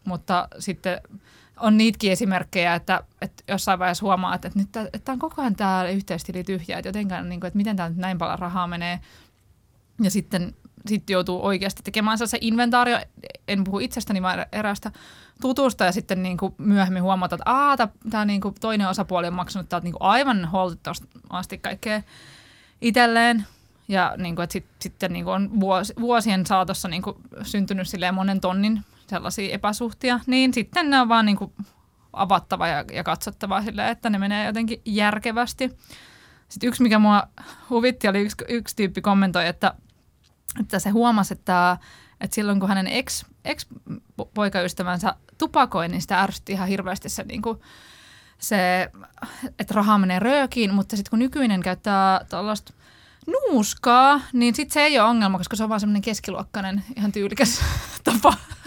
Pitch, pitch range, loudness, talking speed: 200 Hz, 185-225 Hz, -23 LUFS, 150 wpm